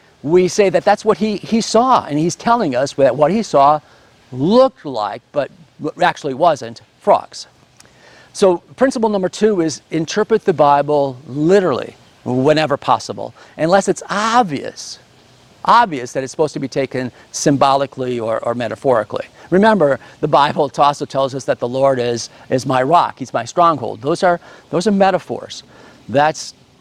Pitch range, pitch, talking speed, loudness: 135-190 Hz, 150 Hz, 155 wpm, -16 LUFS